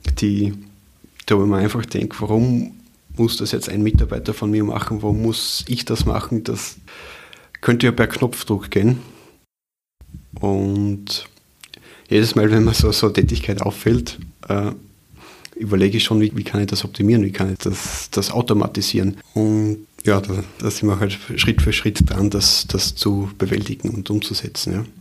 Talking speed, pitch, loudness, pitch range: 170 wpm, 105 Hz, -19 LUFS, 100-110 Hz